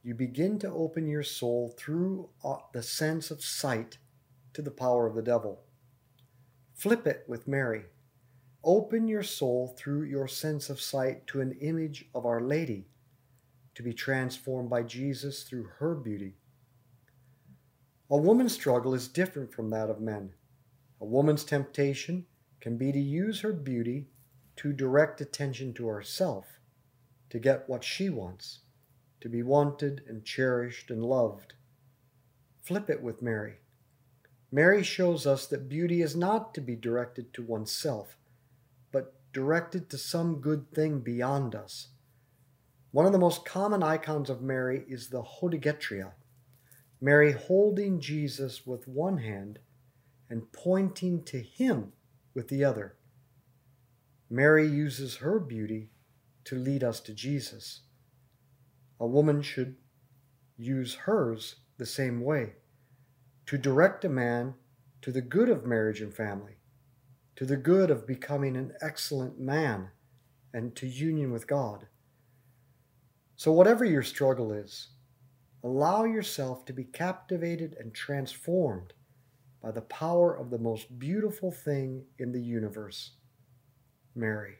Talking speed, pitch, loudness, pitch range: 135 wpm, 130 Hz, -30 LUFS, 125-145 Hz